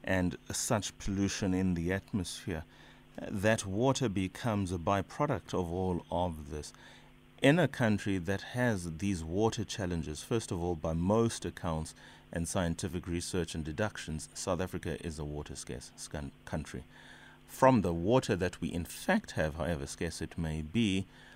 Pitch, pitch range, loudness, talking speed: 90 Hz, 80-105 Hz, -33 LUFS, 155 wpm